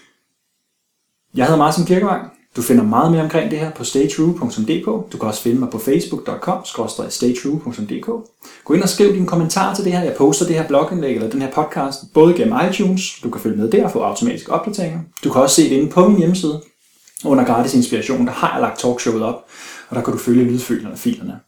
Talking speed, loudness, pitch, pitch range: 210 wpm, -17 LUFS, 165 Hz, 135-195 Hz